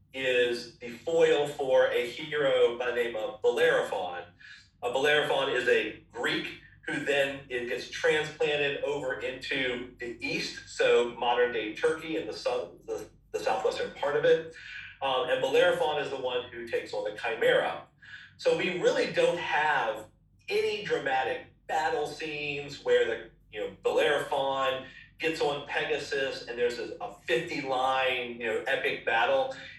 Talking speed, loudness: 145 wpm, -29 LUFS